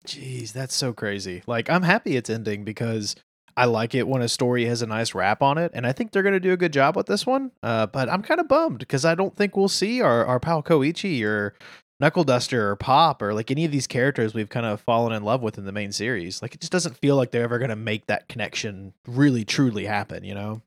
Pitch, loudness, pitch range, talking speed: 125 Hz, -23 LUFS, 110-165 Hz, 260 wpm